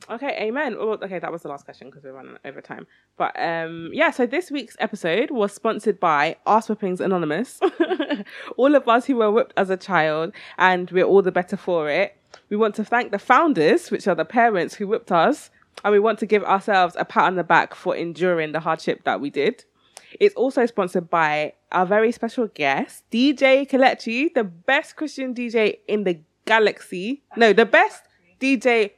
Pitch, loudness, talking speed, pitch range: 215 Hz, -21 LUFS, 195 wpm, 180-250 Hz